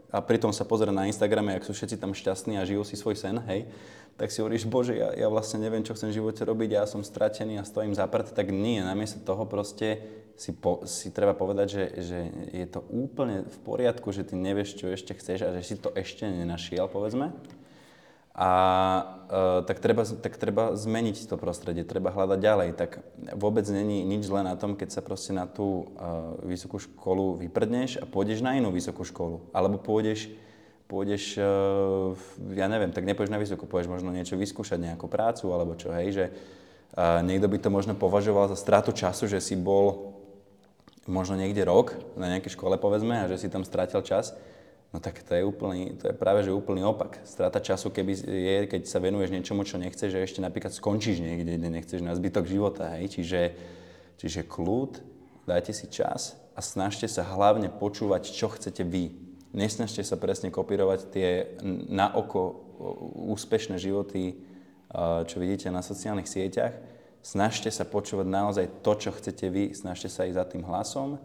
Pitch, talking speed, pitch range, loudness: 95 Hz, 185 wpm, 90-105 Hz, -29 LUFS